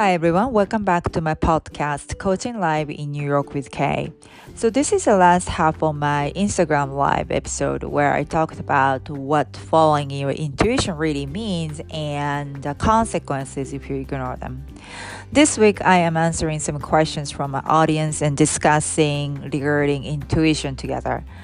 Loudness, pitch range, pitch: -20 LUFS, 140-165 Hz, 150 Hz